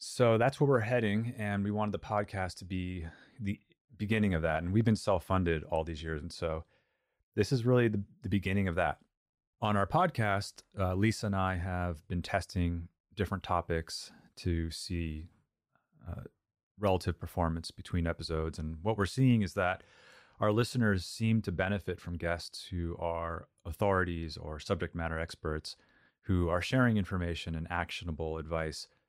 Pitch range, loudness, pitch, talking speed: 85-105 Hz, -33 LUFS, 95 Hz, 165 wpm